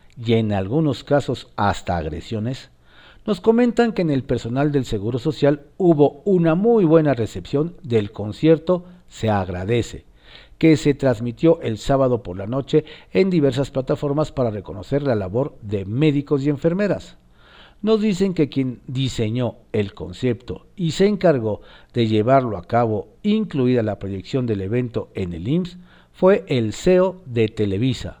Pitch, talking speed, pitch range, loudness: 130 Hz, 150 wpm, 110-155 Hz, -20 LUFS